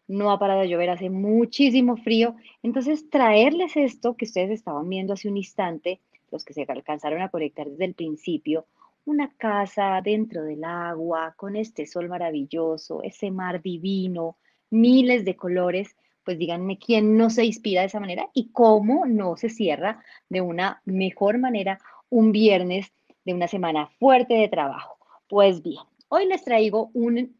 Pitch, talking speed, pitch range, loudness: 200 Hz, 160 wpm, 180-230 Hz, -23 LUFS